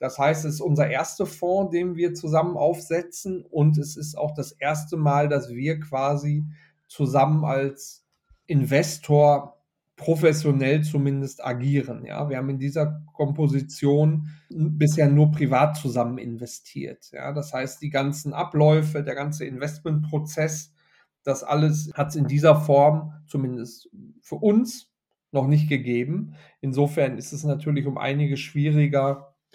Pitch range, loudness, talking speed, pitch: 140-155 Hz, -23 LUFS, 135 wpm, 150 Hz